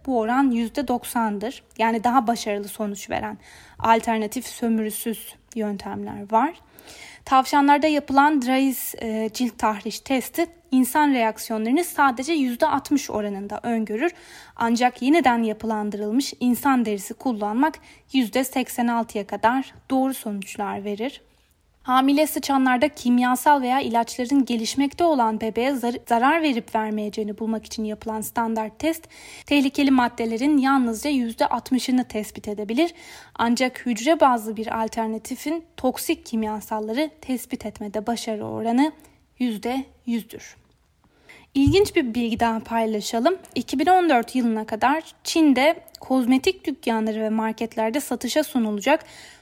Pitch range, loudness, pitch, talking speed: 225-280 Hz, -23 LUFS, 245 Hz, 105 wpm